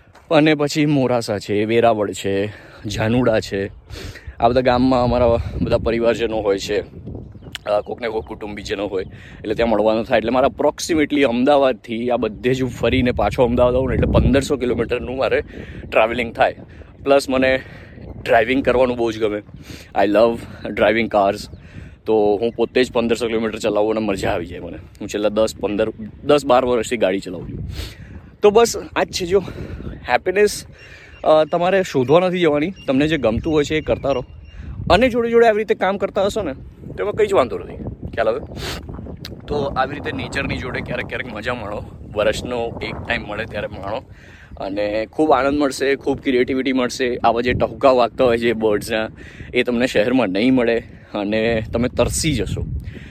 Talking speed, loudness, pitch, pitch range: 170 wpm, -19 LUFS, 115 Hz, 105-135 Hz